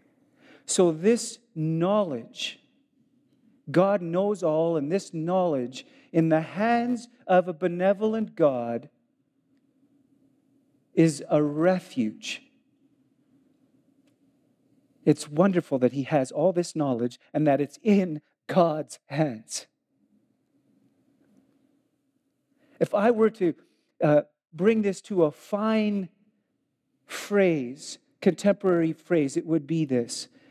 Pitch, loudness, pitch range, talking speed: 205 Hz, -25 LUFS, 165-275 Hz, 100 wpm